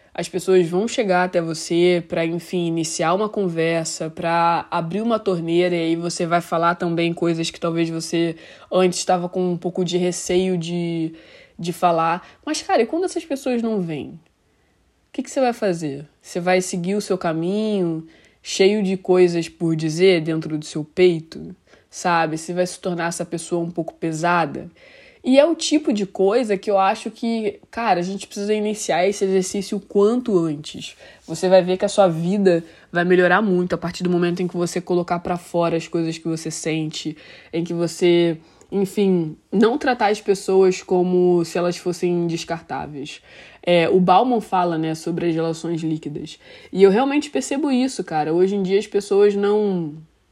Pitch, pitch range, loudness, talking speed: 180 Hz, 170-200 Hz, -20 LUFS, 180 wpm